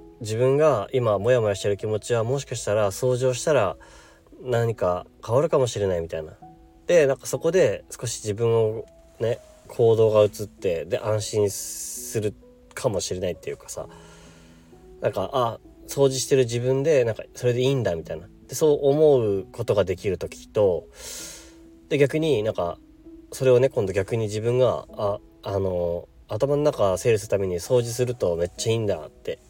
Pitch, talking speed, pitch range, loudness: 115 Hz, 330 characters per minute, 100-130 Hz, -23 LUFS